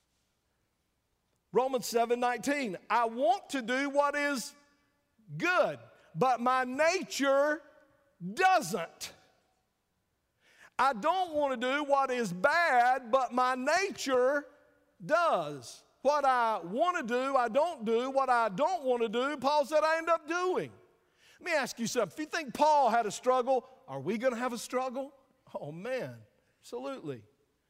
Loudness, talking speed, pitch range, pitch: -30 LUFS, 145 wpm, 240-295 Hz, 265 Hz